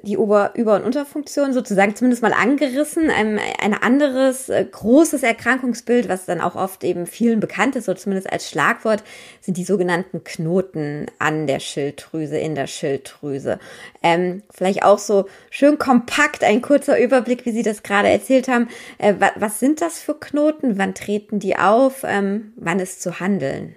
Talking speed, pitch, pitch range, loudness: 170 wpm, 210 Hz, 185-255 Hz, -19 LUFS